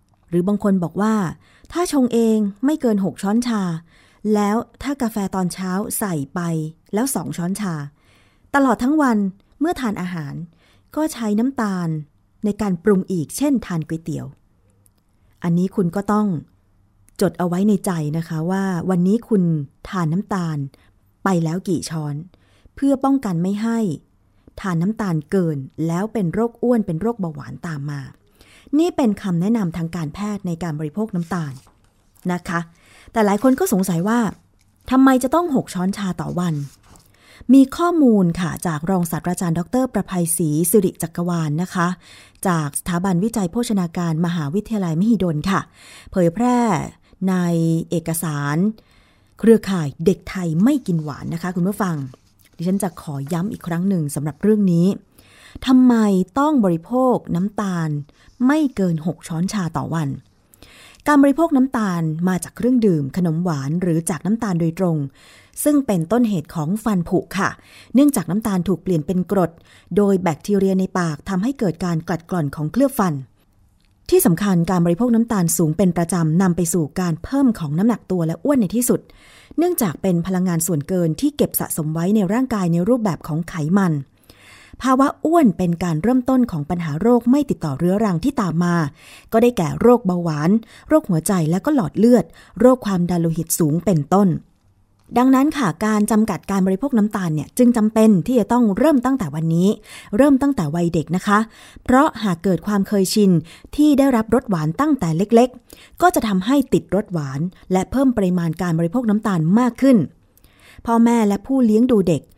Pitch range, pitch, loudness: 165-225 Hz, 185 Hz, -19 LUFS